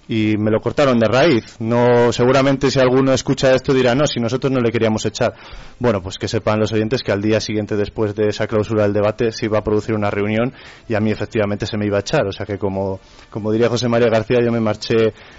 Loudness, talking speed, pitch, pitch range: -17 LUFS, 245 wpm, 110 Hz, 105-120 Hz